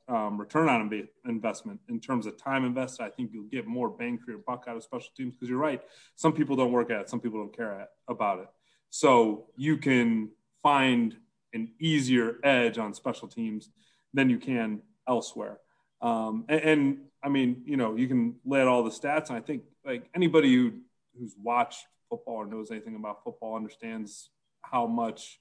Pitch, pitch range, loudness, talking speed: 130 Hz, 115-160 Hz, -29 LUFS, 195 wpm